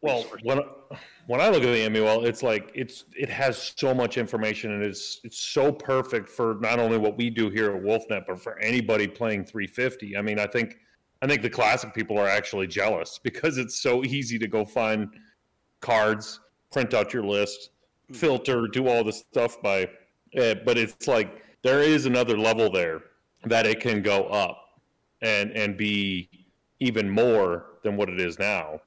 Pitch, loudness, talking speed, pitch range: 110 Hz, -25 LUFS, 185 wpm, 105-120 Hz